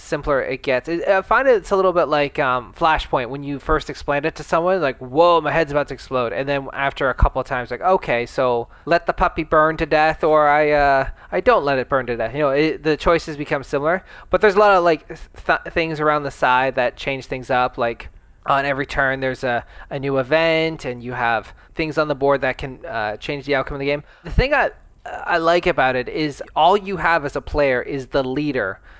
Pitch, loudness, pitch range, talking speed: 145 Hz, -19 LUFS, 130-165 Hz, 240 wpm